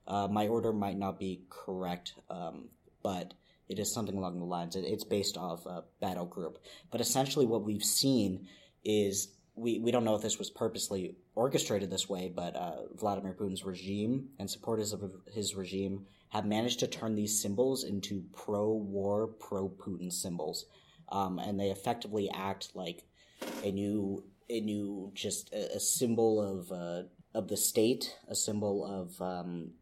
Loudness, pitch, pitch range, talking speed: -35 LUFS, 100 Hz, 95-105 Hz, 165 wpm